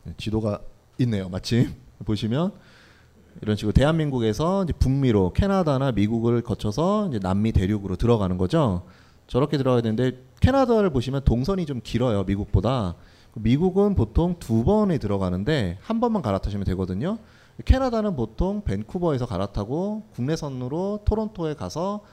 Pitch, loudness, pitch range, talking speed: 125 Hz, -24 LUFS, 105-170 Hz, 355 characters per minute